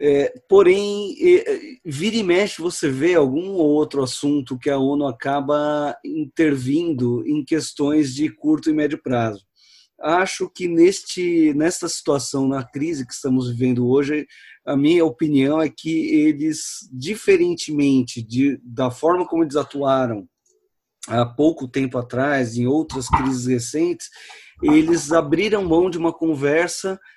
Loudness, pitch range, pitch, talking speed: -20 LUFS, 135-215 Hz, 155 Hz, 135 wpm